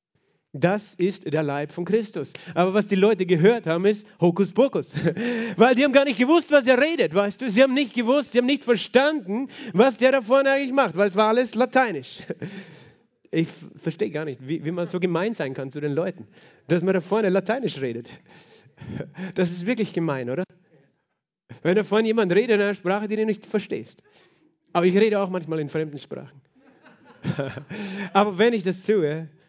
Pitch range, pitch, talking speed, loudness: 165-230 Hz, 195 Hz, 190 wpm, -22 LUFS